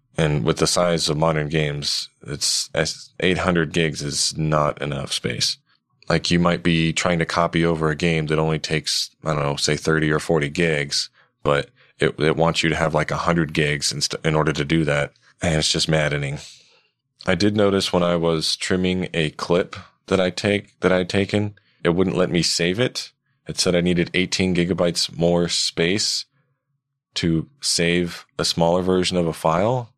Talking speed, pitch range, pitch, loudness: 185 wpm, 80-90 Hz, 85 Hz, -21 LUFS